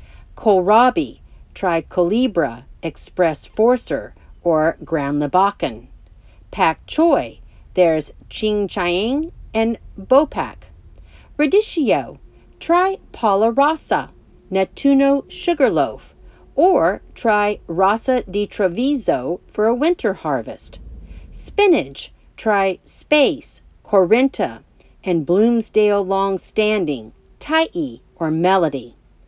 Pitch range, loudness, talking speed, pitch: 180-270 Hz, -18 LUFS, 80 wpm, 210 Hz